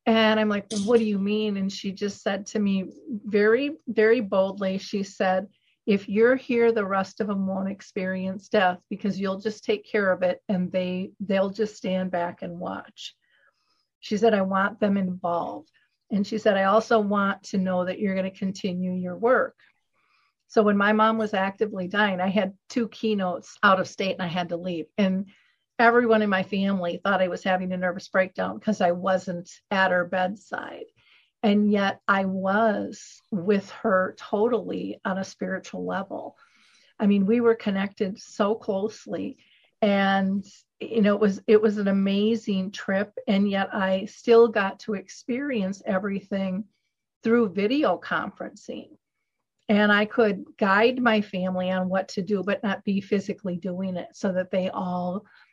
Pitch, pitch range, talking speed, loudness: 200 Hz, 190-215 Hz, 175 wpm, -25 LUFS